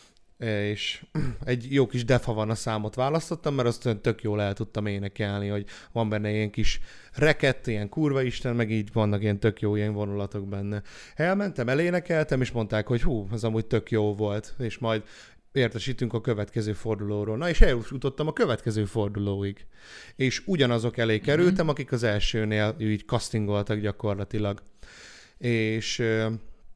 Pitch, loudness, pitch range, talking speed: 110 Hz, -27 LUFS, 105-125 Hz, 150 wpm